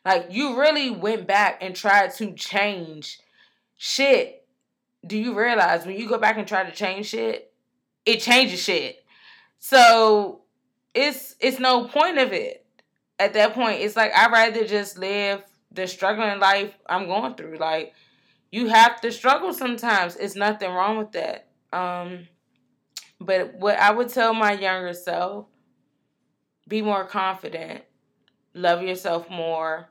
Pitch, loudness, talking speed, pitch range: 210 Hz, -21 LUFS, 145 wpm, 190-245 Hz